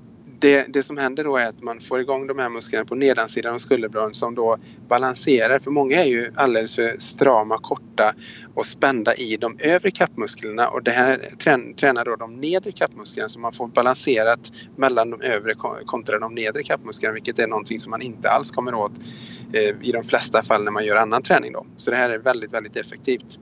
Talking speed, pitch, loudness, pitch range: 205 wpm, 120 Hz, -21 LUFS, 115-135 Hz